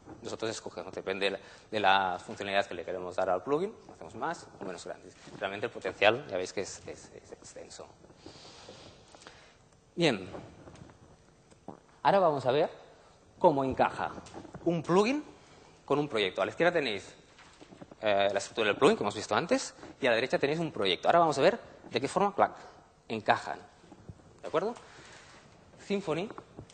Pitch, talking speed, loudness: 130 Hz, 165 wpm, -30 LUFS